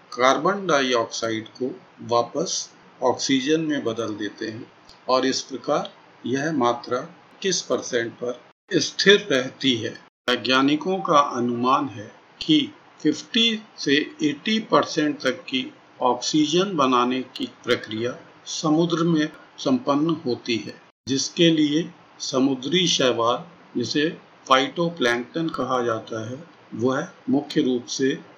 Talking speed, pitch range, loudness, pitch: 110 wpm, 125-165 Hz, -23 LUFS, 135 Hz